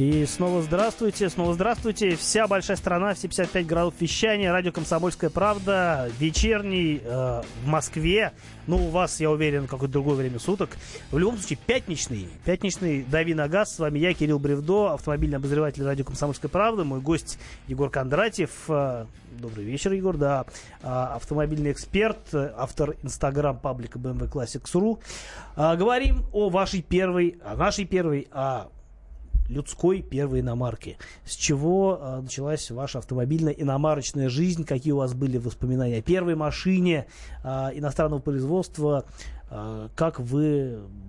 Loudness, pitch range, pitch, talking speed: -26 LUFS, 130-180 Hz, 150 Hz, 135 wpm